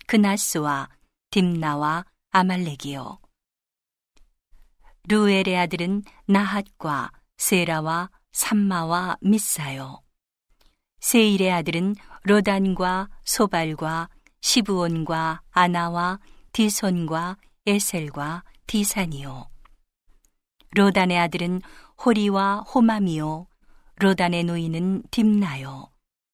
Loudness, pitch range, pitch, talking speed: -23 LUFS, 160-200 Hz, 180 Hz, 185 characters per minute